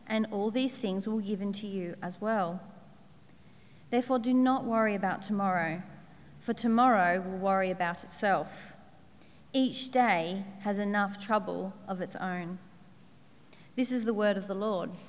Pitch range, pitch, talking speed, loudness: 180-225 Hz, 200 Hz, 150 wpm, -30 LUFS